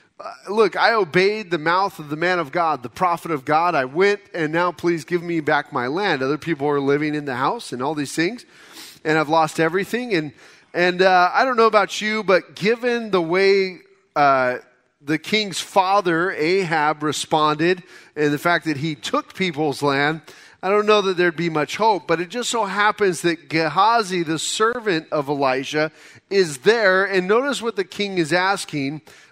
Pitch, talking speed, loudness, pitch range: 175 Hz, 205 wpm, -20 LUFS, 155-195 Hz